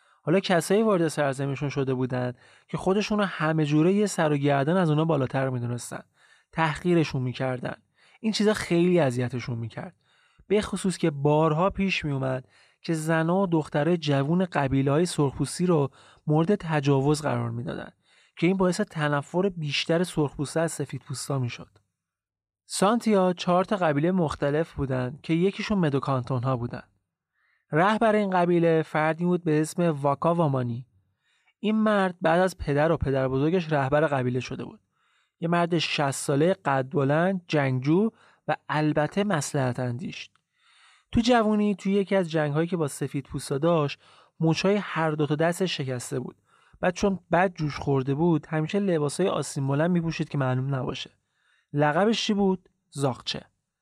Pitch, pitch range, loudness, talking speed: 155 Hz, 140-180 Hz, -25 LUFS, 145 wpm